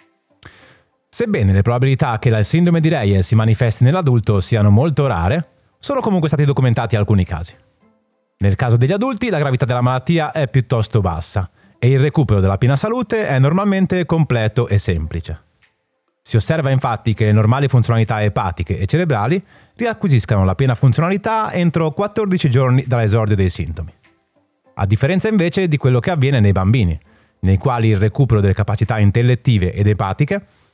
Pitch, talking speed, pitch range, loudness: 125 Hz, 155 wpm, 105-155 Hz, -16 LUFS